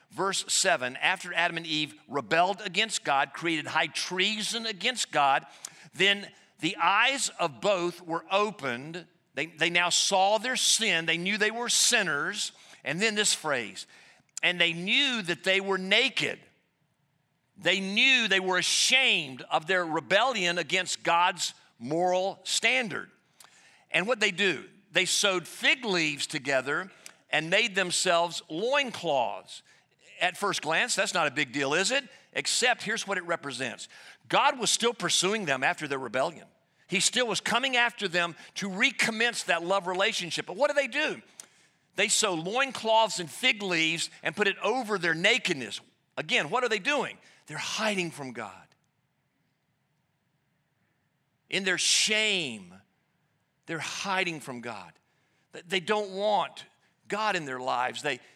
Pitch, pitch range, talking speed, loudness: 185 Hz, 165-215 Hz, 145 wpm, -26 LUFS